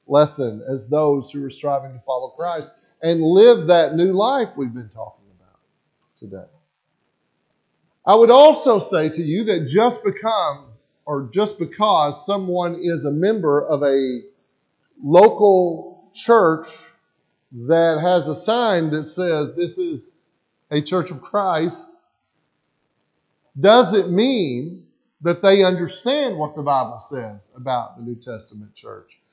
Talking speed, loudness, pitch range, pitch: 135 wpm, -18 LUFS, 140-200 Hz, 165 Hz